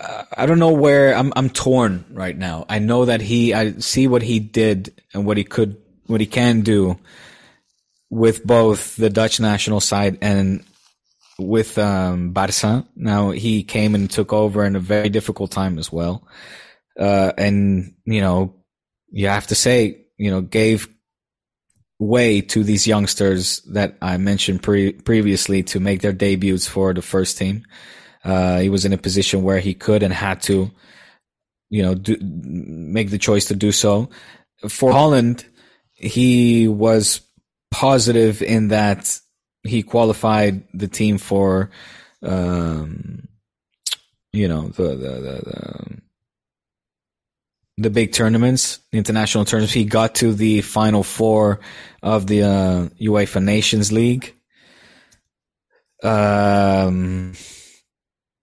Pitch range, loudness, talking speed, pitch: 95-110 Hz, -18 LUFS, 140 wpm, 105 Hz